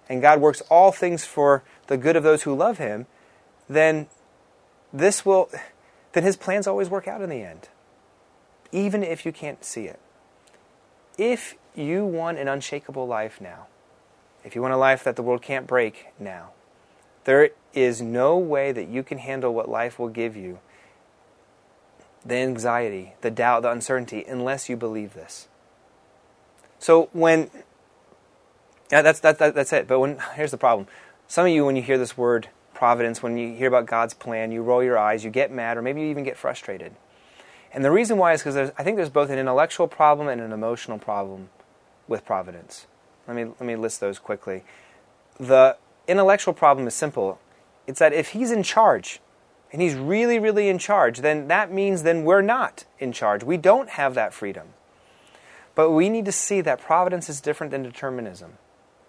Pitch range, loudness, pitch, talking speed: 120-165 Hz, -22 LUFS, 140 Hz, 185 wpm